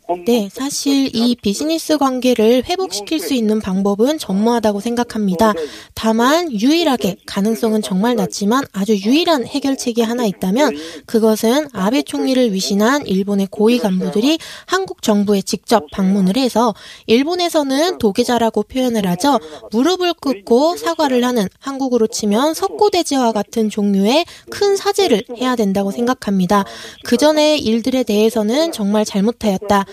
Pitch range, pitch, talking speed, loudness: 210-275 Hz, 230 Hz, 330 characters per minute, -16 LUFS